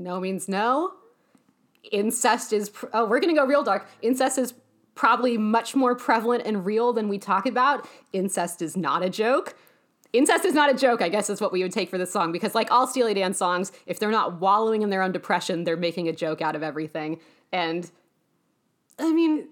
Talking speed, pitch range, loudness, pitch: 210 wpm, 180-245 Hz, -24 LUFS, 205 Hz